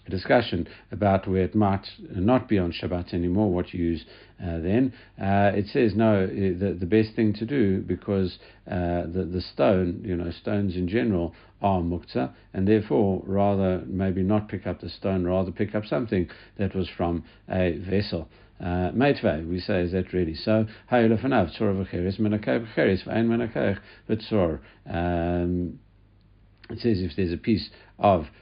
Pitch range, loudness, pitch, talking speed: 90-105 Hz, -25 LUFS, 95 Hz, 150 wpm